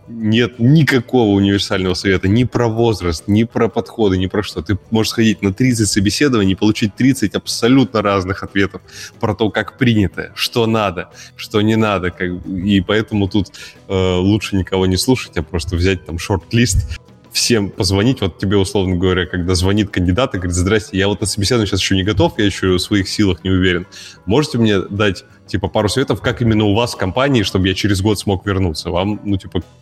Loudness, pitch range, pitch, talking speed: -16 LUFS, 95-110 Hz, 100 Hz, 195 wpm